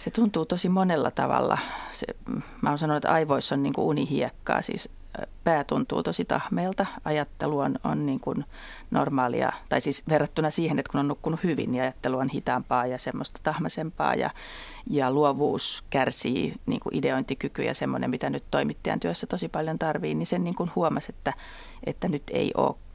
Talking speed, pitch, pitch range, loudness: 180 wpm, 150 Hz, 135-160 Hz, -27 LUFS